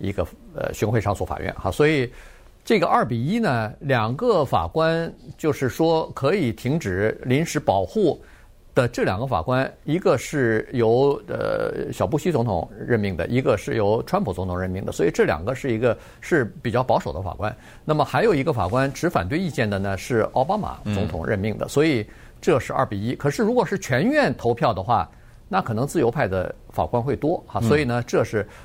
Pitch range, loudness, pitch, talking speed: 105-150 Hz, -23 LUFS, 125 Hz, 290 characters per minute